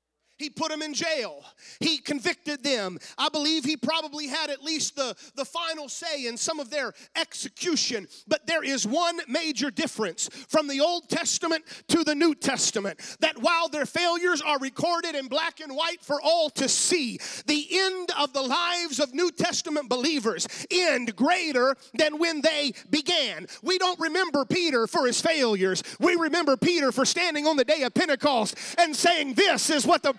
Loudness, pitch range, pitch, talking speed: -25 LUFS, 275-335 Hz, 305 Hz, 180 wpm